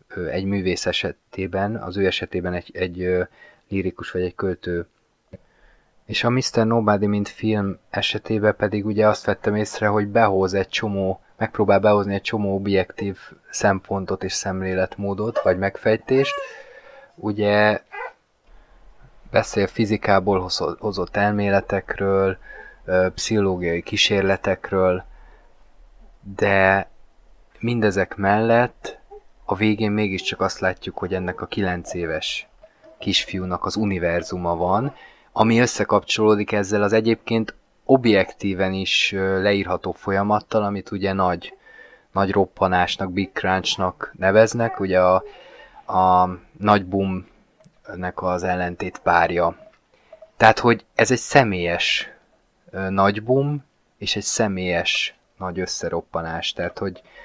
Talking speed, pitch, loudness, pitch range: 105 wpm, 100 Hz, -21 LUFS, 95-110 Hz